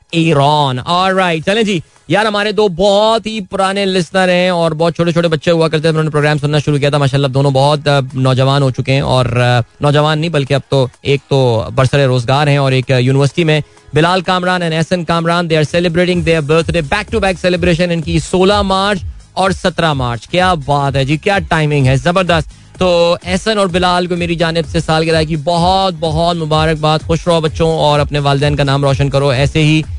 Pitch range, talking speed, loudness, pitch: 140-180 Hz, 205 wpm, -13 LUFS, 160 Hz